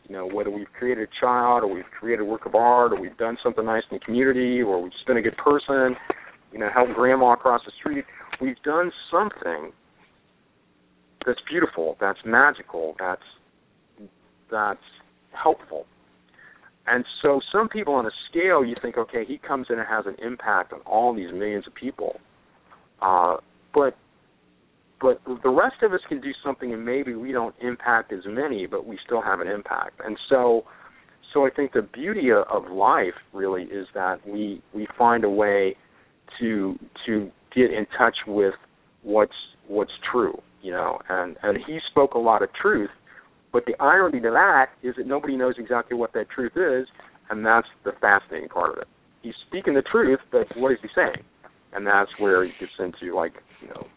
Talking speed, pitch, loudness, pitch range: 185 wpm, 120 Hz, -23 LUFS, 105-130 Hz